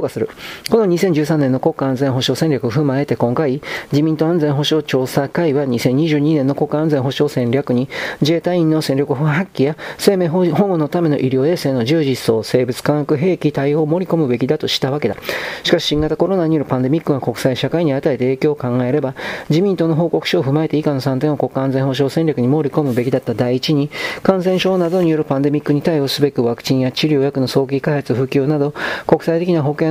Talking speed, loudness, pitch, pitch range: 410 characters per minute, -17 LUFS, 150 Hz, 135-160 Hz